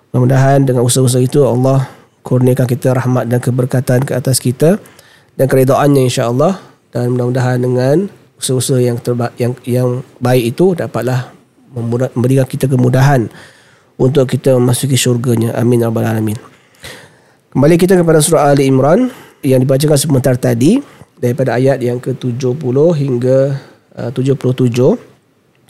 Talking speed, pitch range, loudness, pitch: 125 wpm, 125-135 Hz, -12 LUFS, 130 Hz